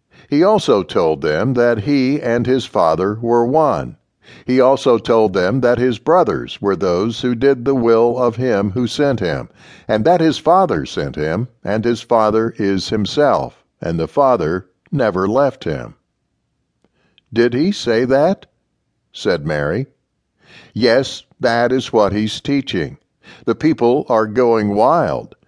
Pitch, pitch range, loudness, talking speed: 120 Hz, 110-130 Hz, -16 LUFS, 150 wpm